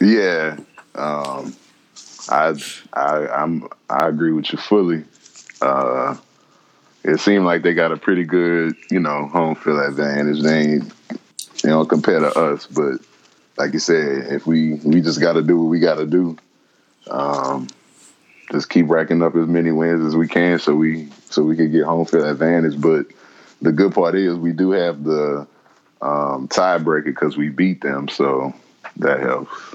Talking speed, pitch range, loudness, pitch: 165 wpm, 75-85 Hz, -18 LUFS, 80 Hz